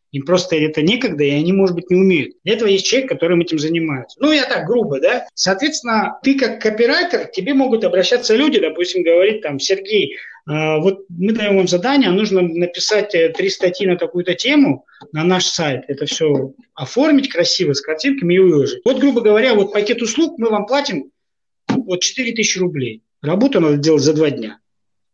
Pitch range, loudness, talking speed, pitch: 160-240 Hz, -16 LUFS, 185 wpm, 185 Hz